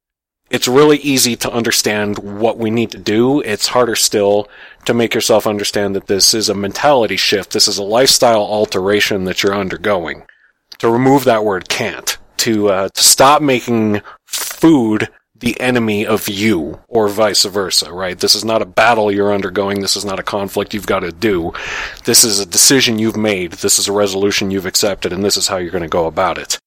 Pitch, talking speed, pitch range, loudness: 105 Hz, 200 wpm, 100-120 Hz, -13 LUFS